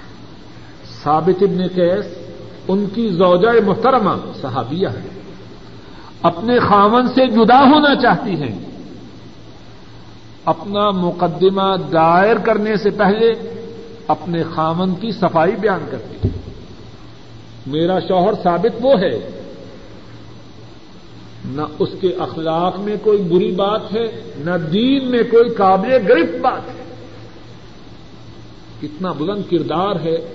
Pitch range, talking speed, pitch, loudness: 165-220 Hz, 110 wpm, 190 Hz, -16 LUFS